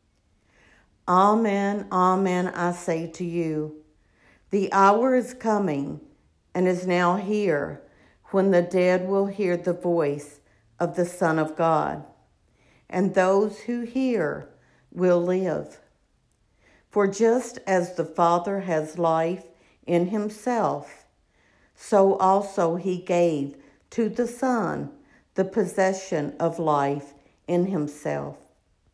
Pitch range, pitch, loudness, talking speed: 155-195 Hz, 180 Hz, -24 LUFS, 110 wpm